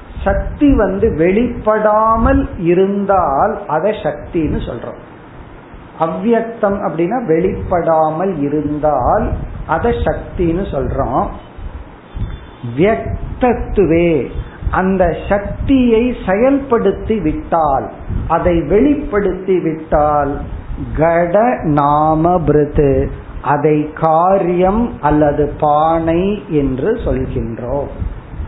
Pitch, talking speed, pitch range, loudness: 170 Hz, 50 wpm, 150-205 Hz, -15 LUFS